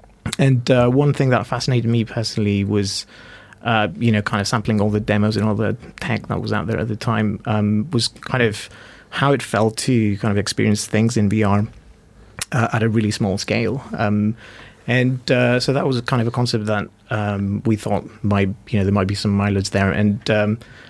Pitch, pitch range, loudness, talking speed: 110 Hz, 105-120 Hz, -19 LUFS, 210 wpm